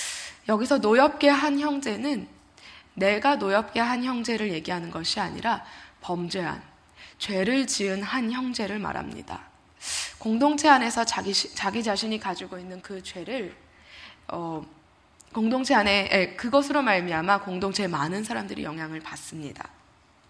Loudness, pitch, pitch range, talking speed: -25 LUFS, 205 Hz, 185-250 Hz, 285 characters per minute